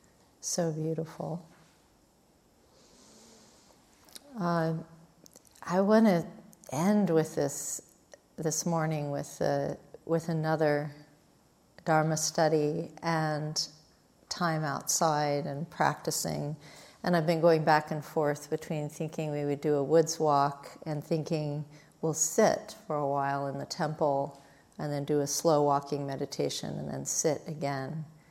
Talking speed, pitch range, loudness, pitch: 125 wpm, 145-165 Hz, -30 LUFS, 155 Hz